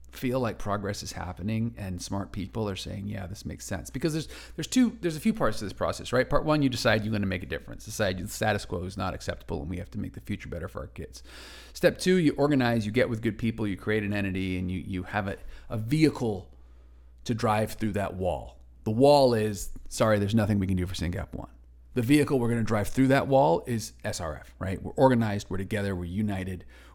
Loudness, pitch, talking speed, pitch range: -28 LUFS, 105 Hz, 240 wpm, 90-115 Hz